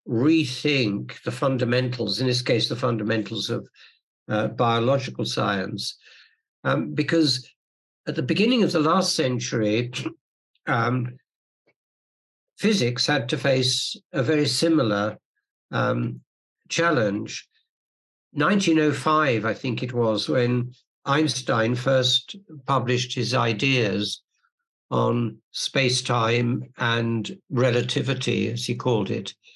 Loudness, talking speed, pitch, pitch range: -23 LUFS, 105 wpm, 125 Hz, 115-150 Hz